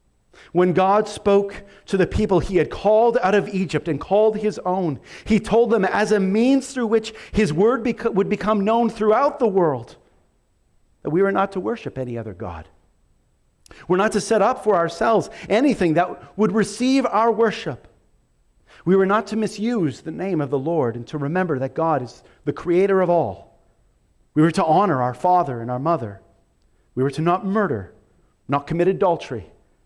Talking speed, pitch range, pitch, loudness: 185 wpm, 145-215 Hz, 190 Hz, -20 LUFS